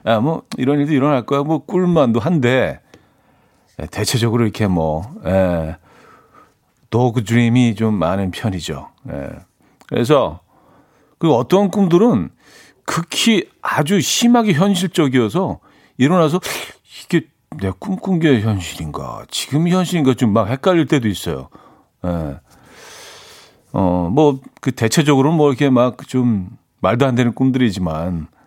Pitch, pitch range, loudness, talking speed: 125 Hz, 105-155 Hz, -17 LUFS, 240 characters per minute